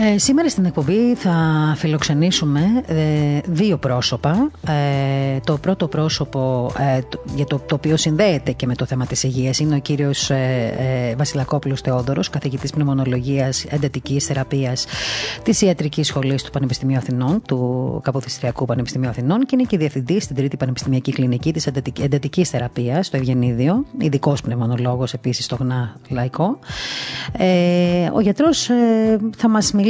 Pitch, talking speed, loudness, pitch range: 140 Hz, 145 wpm, -19 LUFS, 130-165 Hz